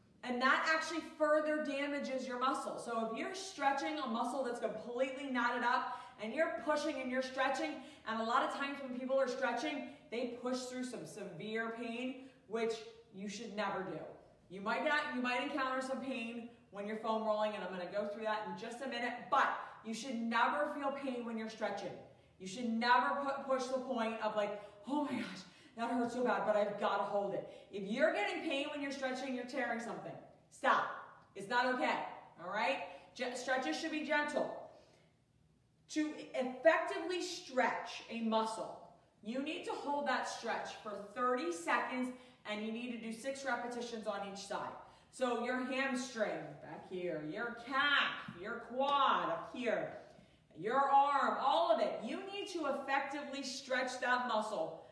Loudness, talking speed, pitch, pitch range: -37 LUFS, 180 wpm, 250 Hz, 220-275 Hz